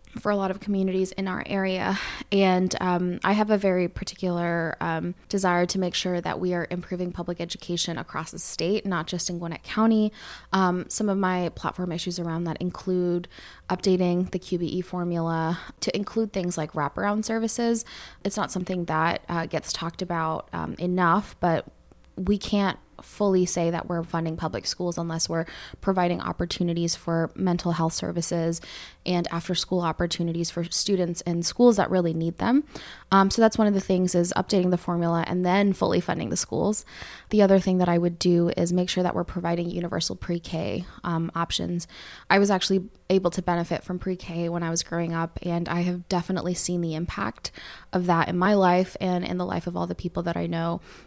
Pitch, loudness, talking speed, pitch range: 180 Hz, -25 LUFS, 195 wpm, 170-190 Hz